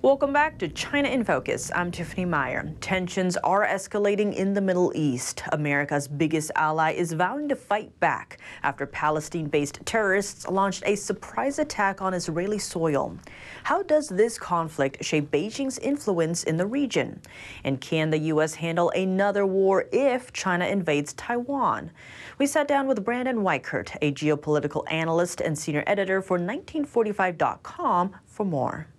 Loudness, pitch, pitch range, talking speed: -26 LUFS, 180 Hz, 155-210 Hz, 145 wpm